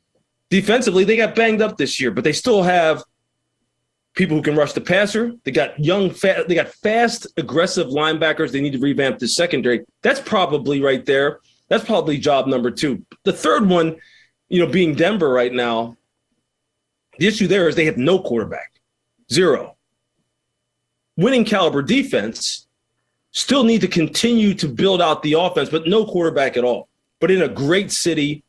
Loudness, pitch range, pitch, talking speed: -18 LUFS, 145-195 Hz, 165 Hz, 170 wpm